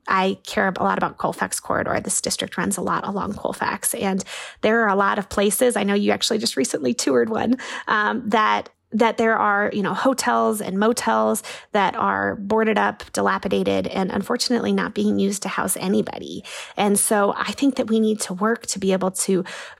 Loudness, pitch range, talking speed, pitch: -21 LUFS, 190-225 Hz, 195 wpm, 205 Hz